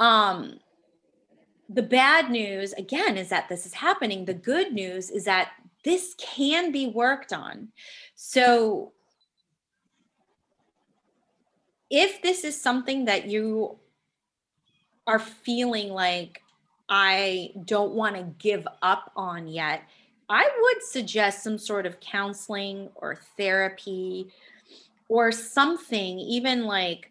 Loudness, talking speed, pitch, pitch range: -25 LUFS, 115 wpm, 215 Hz, 190-250 Hz